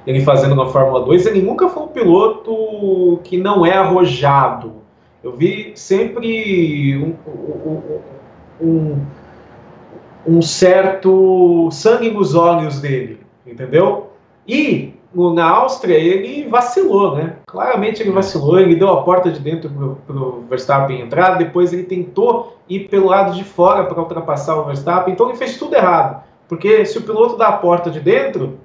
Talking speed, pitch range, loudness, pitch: 150 wpm, 155-200 Hz, -14 LUFS, 180 Hz